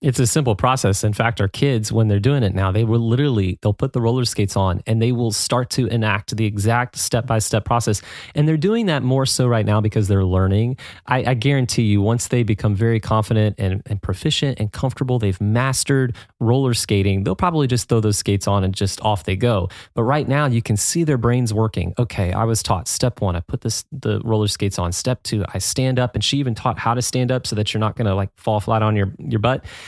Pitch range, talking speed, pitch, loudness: 105-125 Hz, 265 wpm, 115 Hz, -19 LUFS